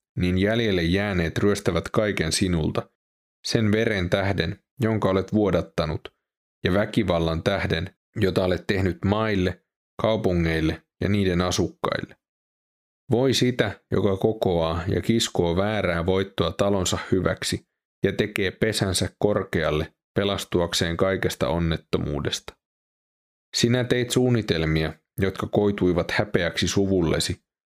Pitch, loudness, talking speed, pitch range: 95 Hz, -24 LUFS, 100 wpm, 85-105 Hz